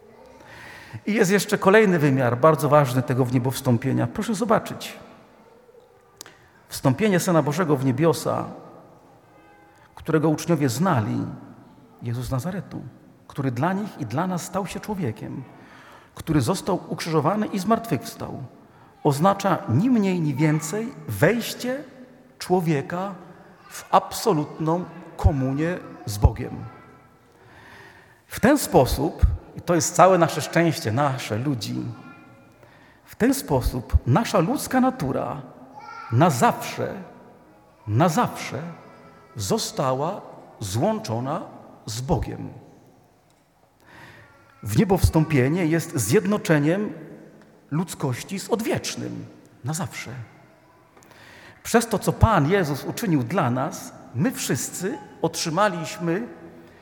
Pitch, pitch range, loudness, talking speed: 165 Hz, 140-195 Hz, -23 LUFS, 100 wpm